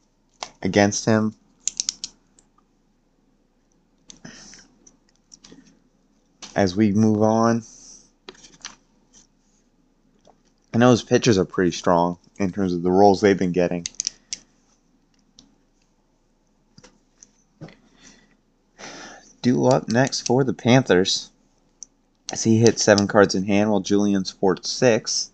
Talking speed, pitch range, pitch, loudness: 90 wpm, 100-125 Hz, 105 Hz, -20 LUFS